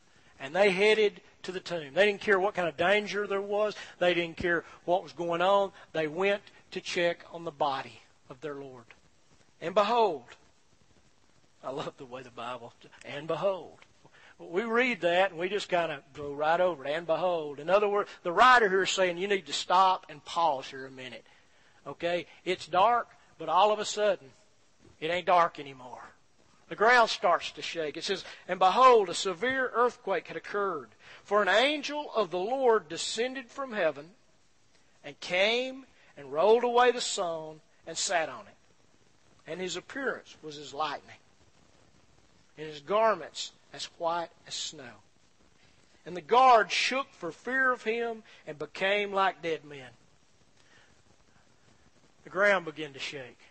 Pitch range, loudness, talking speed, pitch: 155-210 Hz, -28 LUFS, 170 wpm, 180 Hz